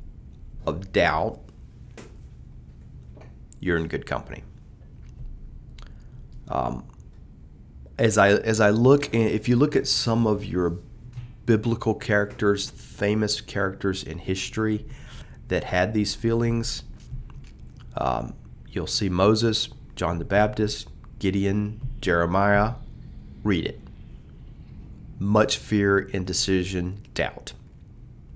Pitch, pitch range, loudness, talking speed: 105 Hz, 95-115 Hz, -24 LUFS, 95 wpm